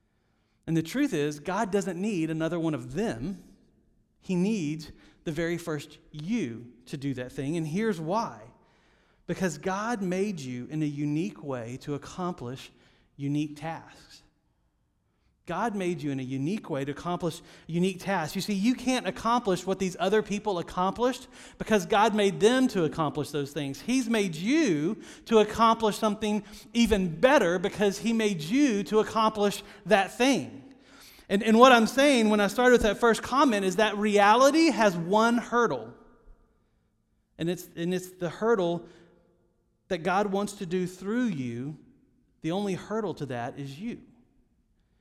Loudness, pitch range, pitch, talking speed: -27 LUFS, 160-220 Hz, 190 Hz, 160 wpm